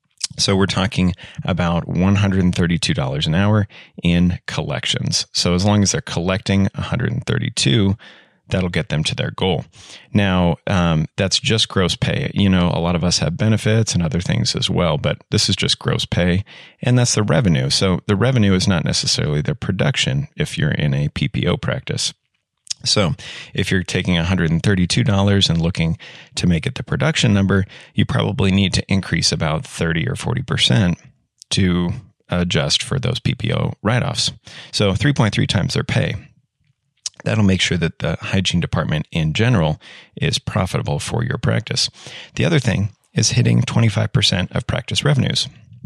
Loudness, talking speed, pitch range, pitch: -18 LUFS, 160 wpm, 90-110 Hz, 100 Hz